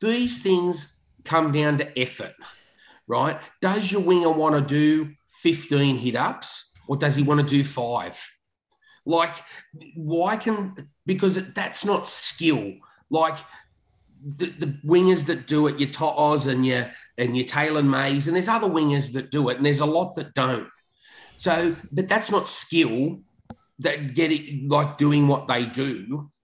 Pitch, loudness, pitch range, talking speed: 150 Hz, -23 LUFS, 140-175 Hz, 165 wpm